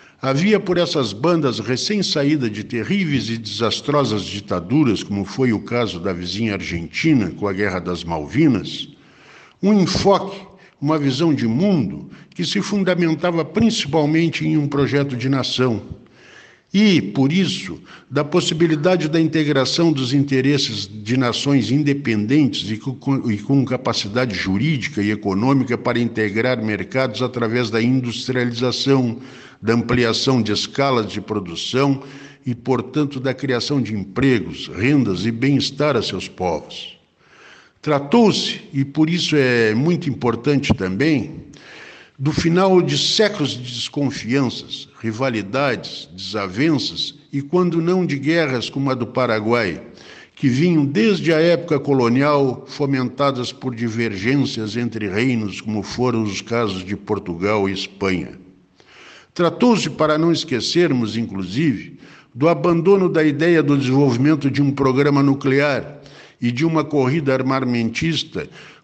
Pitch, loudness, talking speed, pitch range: 135 Hz, -19 LUFS, 125 wpm, 115-155 Hz